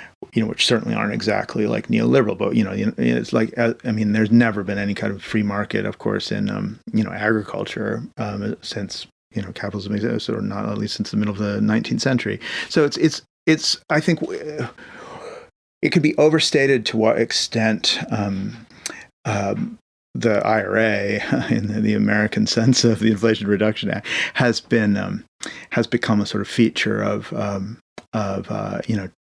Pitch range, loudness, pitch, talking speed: 105-120 Hz, -21 LUFS, 110 Hz, 180 wpm